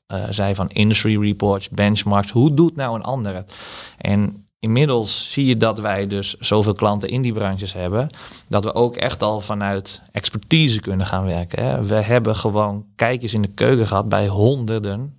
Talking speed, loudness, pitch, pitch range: 180 wpm, -19 LUFS, 105 Hz, 100-120 Hz